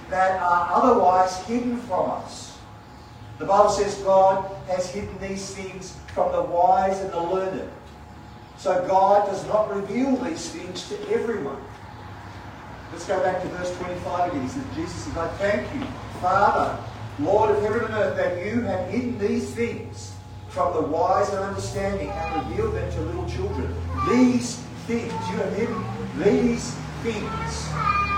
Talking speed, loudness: 155 wpm, -24 LUFS